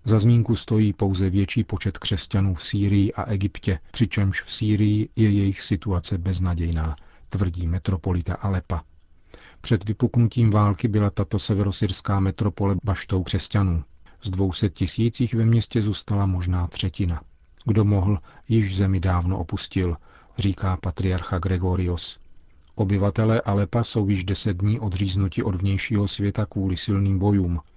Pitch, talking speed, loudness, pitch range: 100 Hz, 130 wpm, -23 LUFS, 90-105 Hz